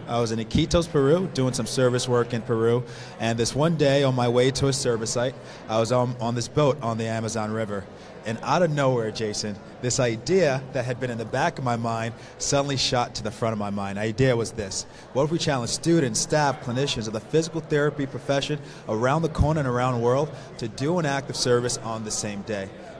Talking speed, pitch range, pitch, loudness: 230 wpm, 115-140 Hz, 125 Hz, -25 LUFS